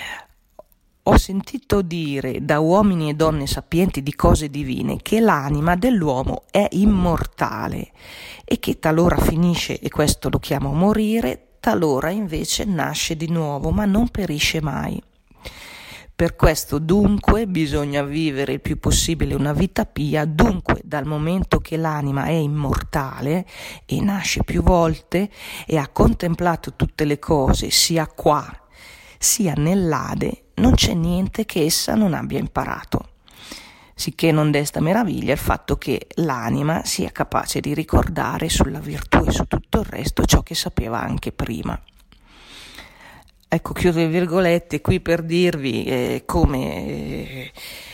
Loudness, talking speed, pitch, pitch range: -20 LUFS, 135 wpm, 165 Hz, 145-185 Hz